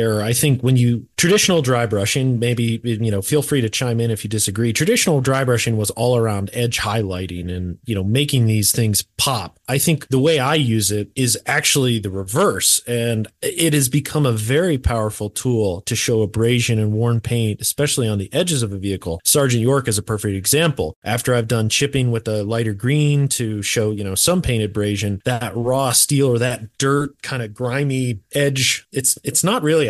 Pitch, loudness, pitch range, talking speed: 120 Hz, -18 LUFS, 110-135 Hz, 200 wpm